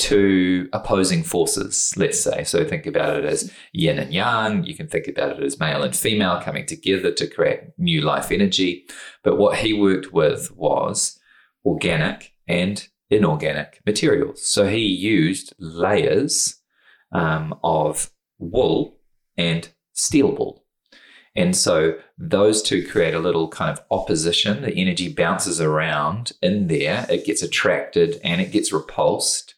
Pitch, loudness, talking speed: 100 Hz, -20 LUFS, 145 wpm